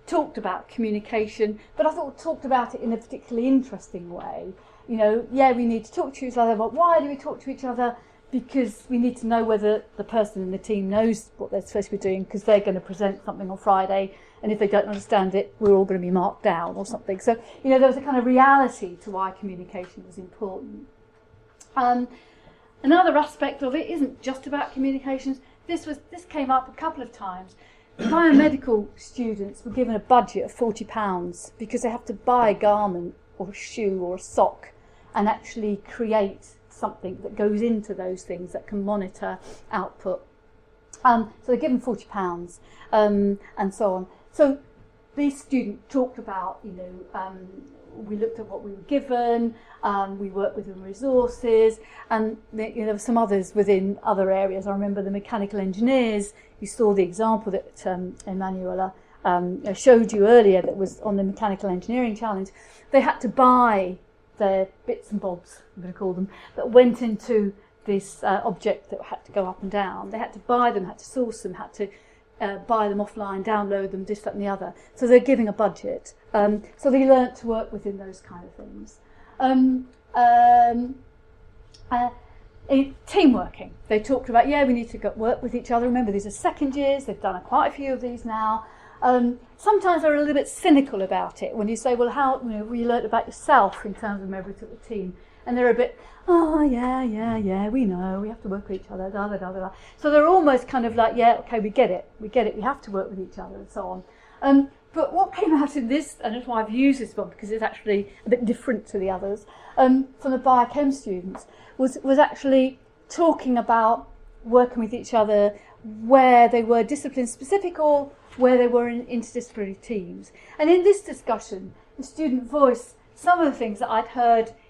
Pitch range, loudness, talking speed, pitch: 200-255 Hz, -23 LUFS, 210 wpm, 225 Hz